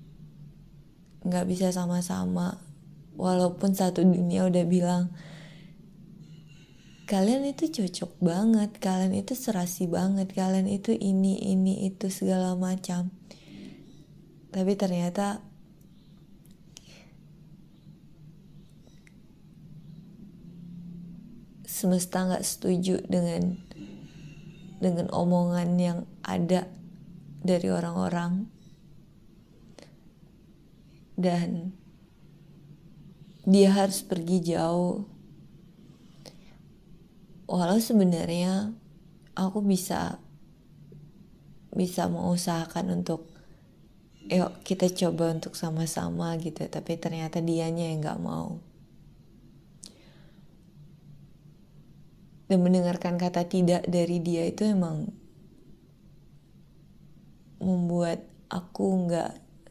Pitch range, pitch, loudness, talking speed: 170-185 Hz, 180 Hz, -28 LUFS, 70 wpm